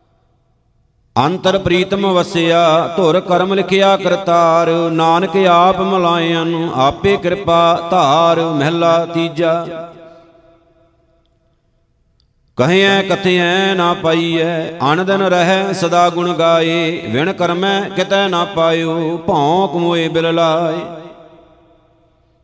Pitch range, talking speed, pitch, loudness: 165-180 Hz, 85 wpm, 170 Hz, -13 LUFS